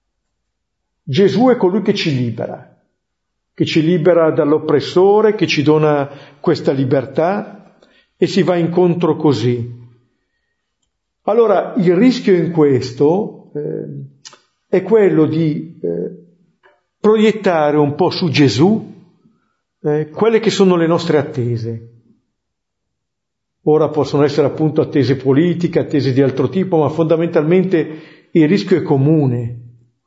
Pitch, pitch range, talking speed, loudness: 160 Hz, 145-185 Hz, 115 wpm, -15 LUFS